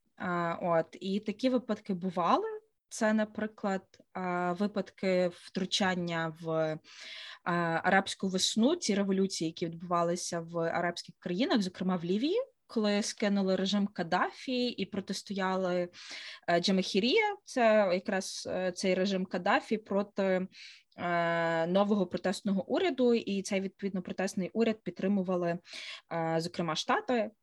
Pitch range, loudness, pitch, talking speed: 180-215 Hz, -31 LUFS, 190 Hz, 100 wpm